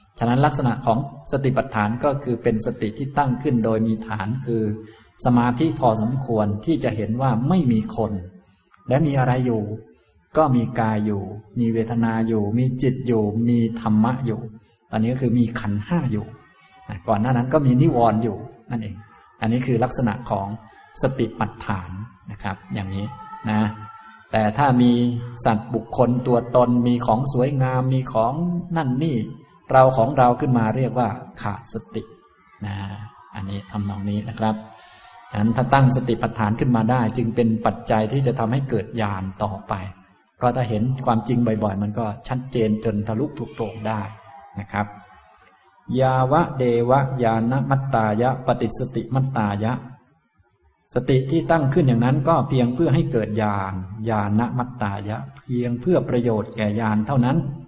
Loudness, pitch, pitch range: -22 LUFS, 115 Hz, 110-130 Hz